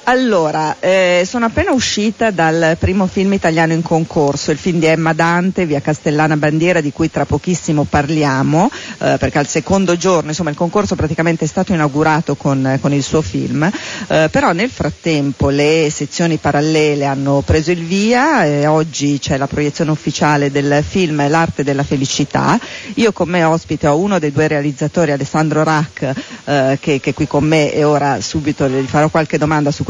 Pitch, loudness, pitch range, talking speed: 155 Hz, -14 LUFS, 145-175 Hz, 175 wpm